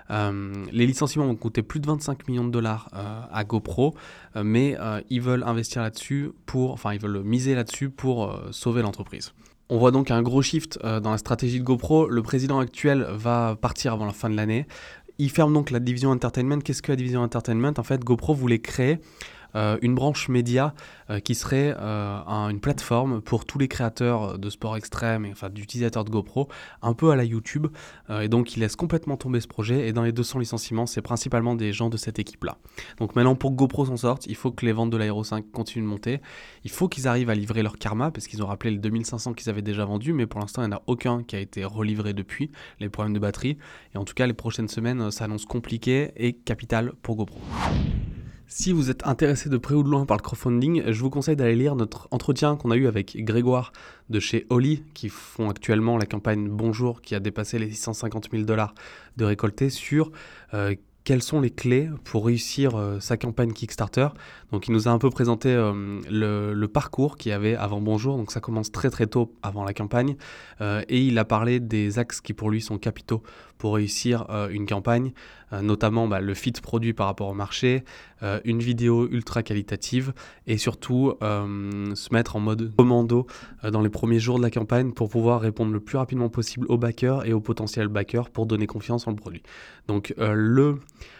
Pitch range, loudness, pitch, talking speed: 105-125 Hz, -25 LUFS, 115 Hz, 220 wpm